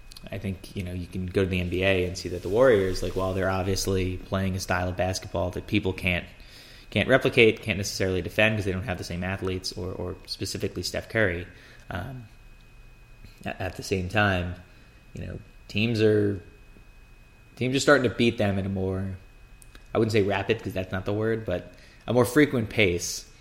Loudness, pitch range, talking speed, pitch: -26 LUFS, 90-110 Hz, 195 wpm, 95 Hz